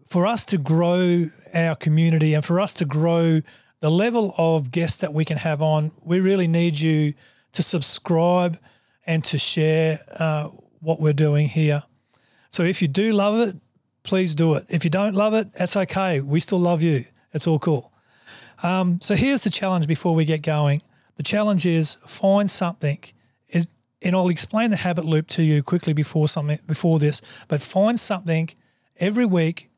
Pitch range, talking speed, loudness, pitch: 155-180 Hz, 180 wpm, -21 LUFS, 165 Hz